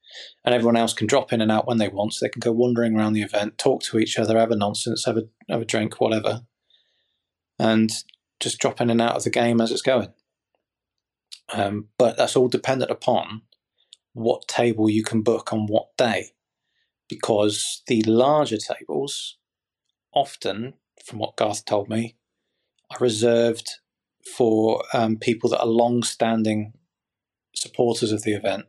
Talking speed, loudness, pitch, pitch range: 165 wpm, -22 LUFS, 115 Hz, 110-120 Hz